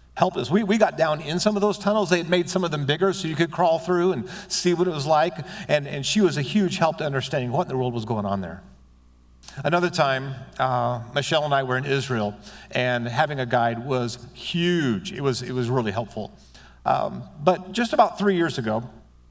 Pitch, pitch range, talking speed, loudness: 145 Hz, 120-175 Hz, 230 wpm, -23 LUFS